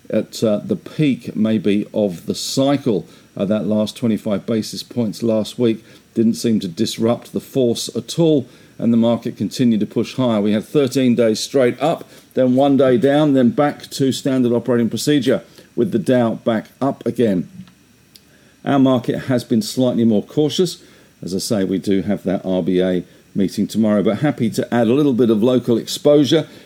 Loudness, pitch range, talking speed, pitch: -18 LUFS, 110-135 Hz, 180 wpm, 120 Hz